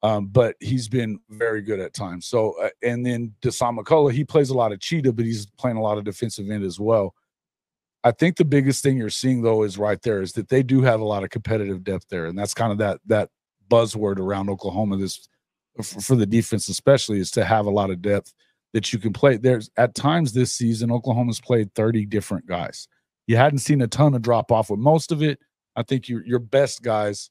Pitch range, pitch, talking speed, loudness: 105-130 Hz, 115 Hz, 230 wpm, -22 LUFS